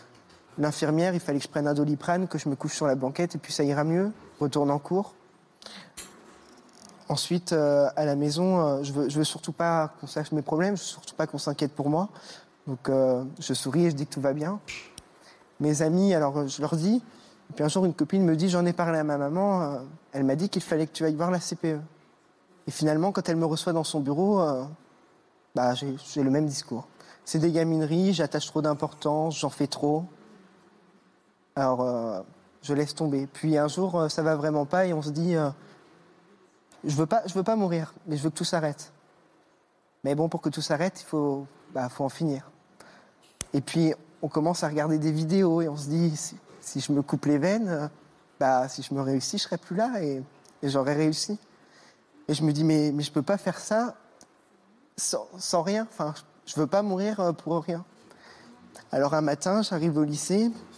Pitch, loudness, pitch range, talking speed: 155 Hz, -27 LUFS, 145-175 Hz, 220 wpm